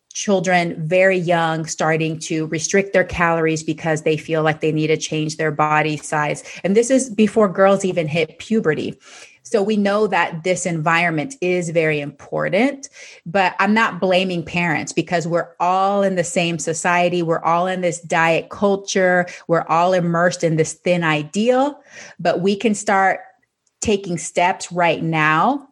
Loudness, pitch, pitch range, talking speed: -18 LUFS, 175 Hz, 160-195 Hz, 160 wpm